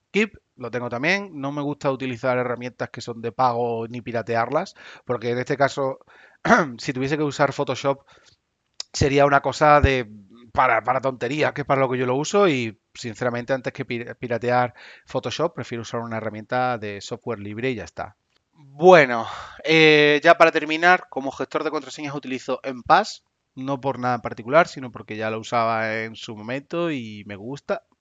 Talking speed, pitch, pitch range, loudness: 175 wpm, 130 Hz, 120-145 Hz, -22 LUFS